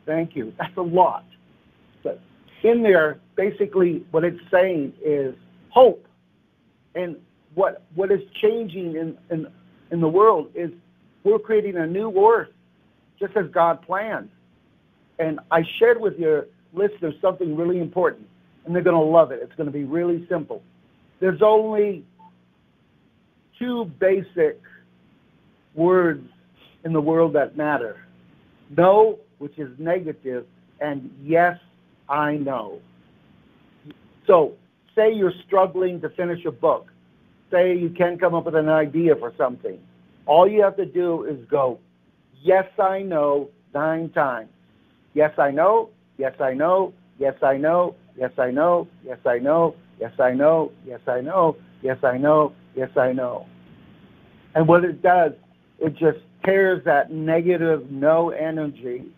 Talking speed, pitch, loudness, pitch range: 140 wpm, 165 Hz, -21 LUFS, 140-185 Hz